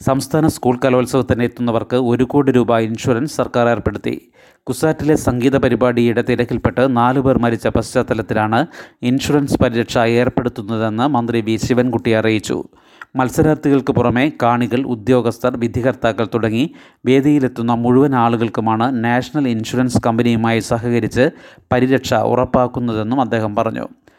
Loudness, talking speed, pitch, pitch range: -16 LUFS, 100 wpm, 120 Hz, 115-130 Hz